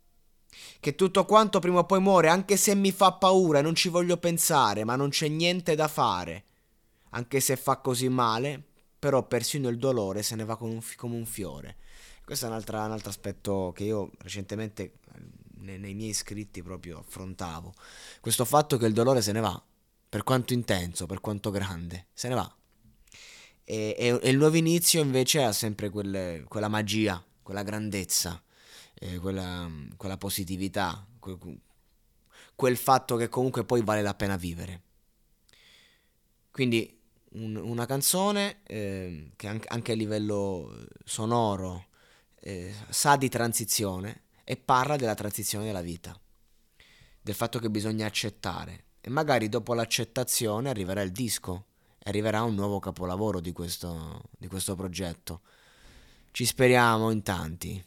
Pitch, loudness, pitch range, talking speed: 110 Hz, -27 LUFS, 95-125 Hz, 145 wpm